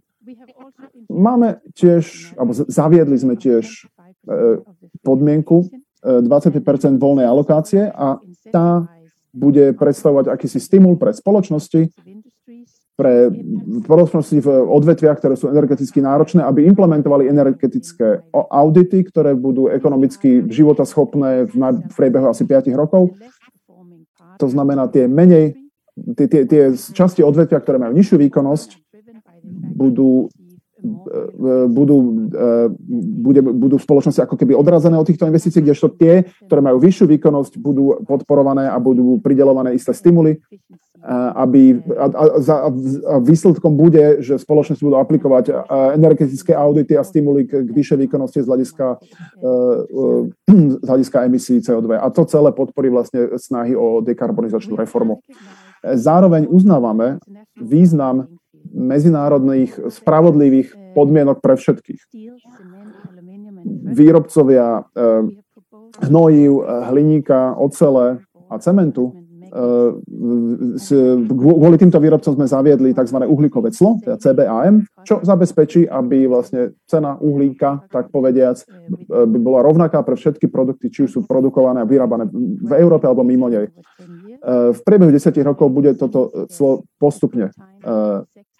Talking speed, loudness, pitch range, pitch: 115 wpm, -14 LUFS, 135-185 Hz, 150 Hz